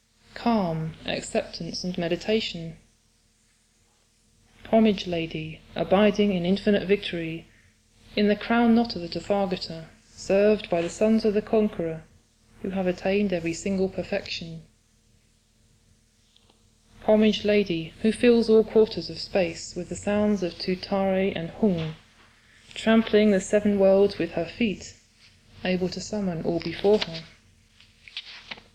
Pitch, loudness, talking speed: 175 Hz, -25 LUFS, 120 wpm